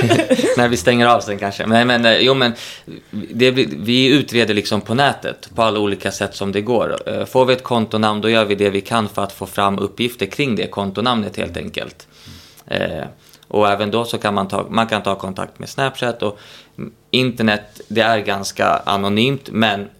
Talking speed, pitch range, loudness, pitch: 195 wpm, 100-120 Hz, -17 LUFS, 110 Hz